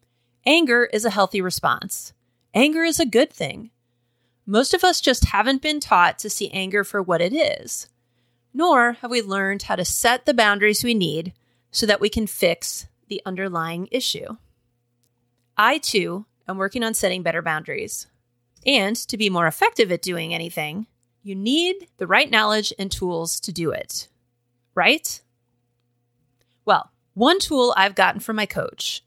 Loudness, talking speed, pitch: -20 LUFS, 160 wpm, 195 Hz